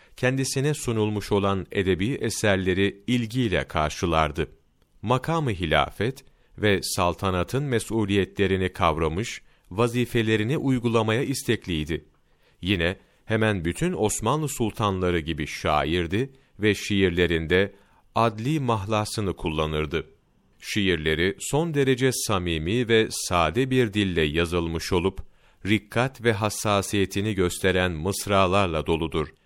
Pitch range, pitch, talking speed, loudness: 85-115 Hz, 100 Hz, 90 wpm, -24 LUFS